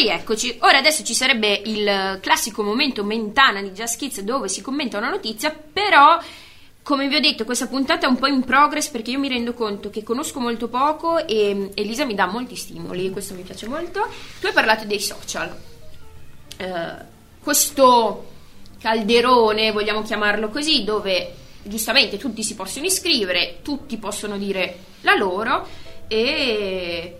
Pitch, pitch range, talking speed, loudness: 230 Hz, 210-285 Hz, 155 wpm, -19 LUFS